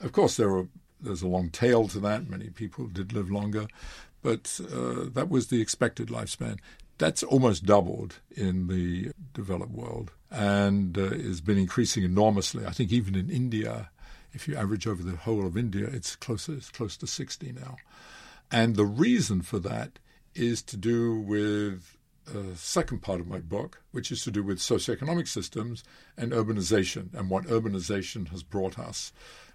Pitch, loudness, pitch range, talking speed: 105 Hz, -29 LUFS, 95-115 Hz, 180 wpm